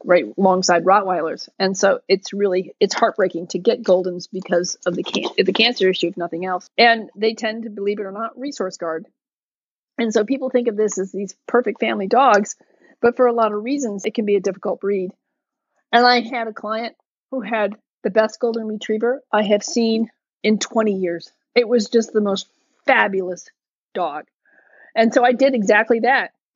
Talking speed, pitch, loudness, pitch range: 190 wpm, 220 Hz, -19 LUFS, 195-240 Hz